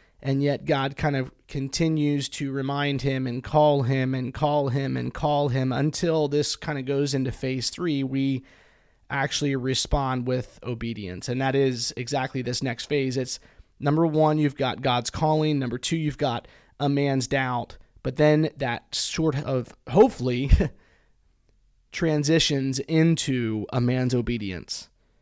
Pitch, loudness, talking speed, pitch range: 135 Hz, -25 LUFS, 150 wpm, 125-145 Hz